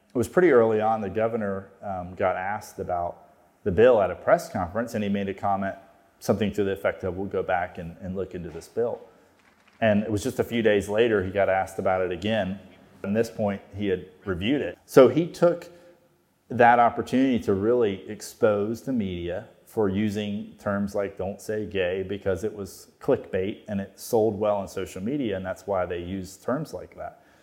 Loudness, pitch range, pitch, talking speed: -25 LUFS, 95-110 Hz, 100 Hz, 205 wpm